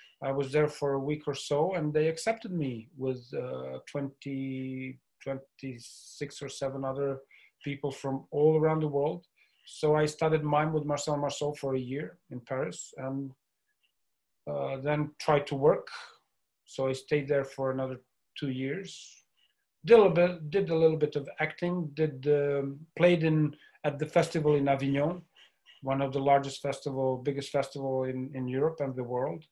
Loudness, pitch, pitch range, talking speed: -30 LUFS, 145 Hz, 135-155 Hz, 170 wpm